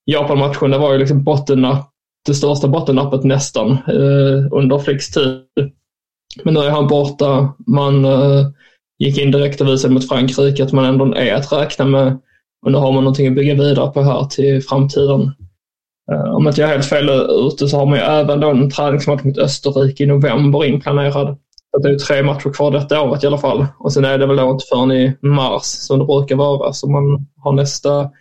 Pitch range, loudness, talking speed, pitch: 135-145 Hz, -14 LUFS, 200 wpm, 140 Hz